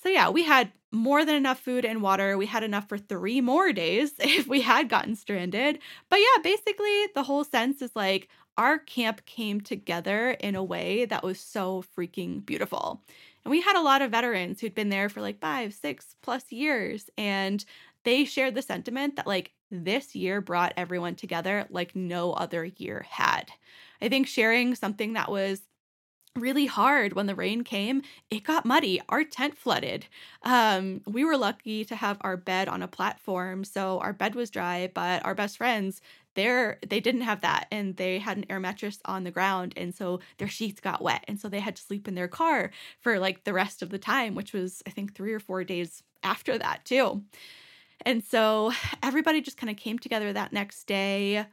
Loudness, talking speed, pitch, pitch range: -27 LUFS, 200 wpm, 210 Hz, 195-255 Hz